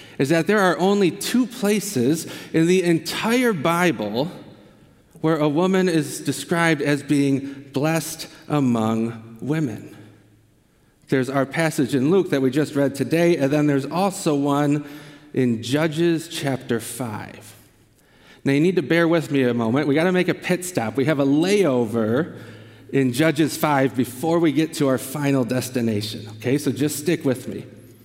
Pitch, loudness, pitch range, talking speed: 145 Hz, -21 LUFS, 125-165 Hz, 165 wpm